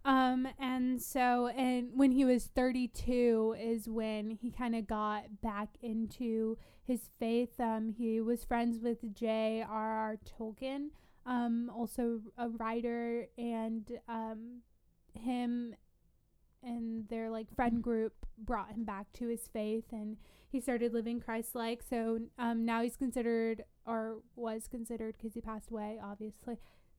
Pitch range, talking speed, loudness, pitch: 225-245 Hz, 140 wpm, -37 LUFS, 230 Hz